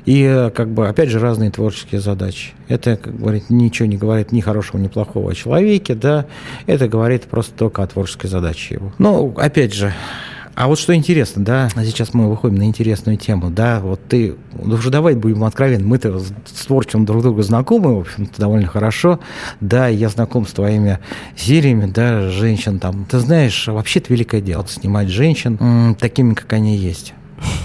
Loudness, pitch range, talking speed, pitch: -16 LUFS, 105-125 Hz, 175 wpm, 115 Hz